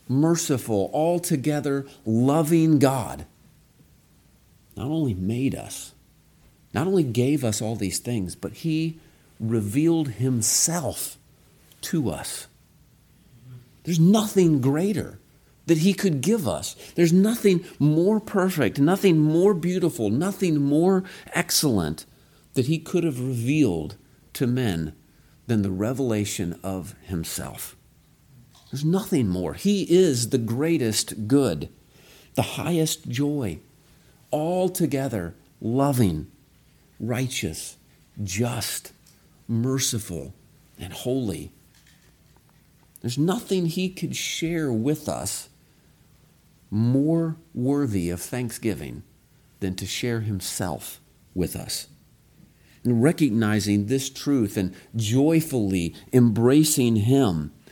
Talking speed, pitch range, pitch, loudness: 100 wpm, 110-160 Hz, 135 Hz, -24 LUFS